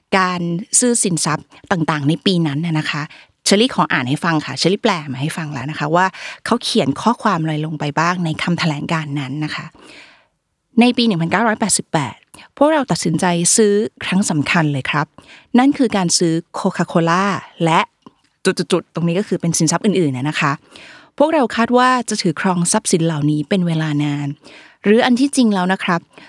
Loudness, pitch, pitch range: -17 LUFS, 175 Hz, 155-215 Hz